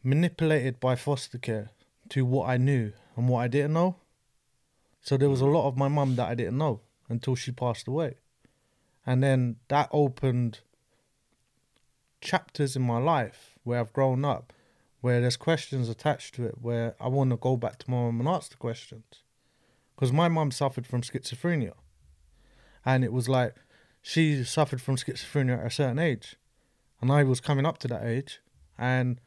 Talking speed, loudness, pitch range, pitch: 180 wpm, -28 LUFS, 120-140 Hz, 130 Hz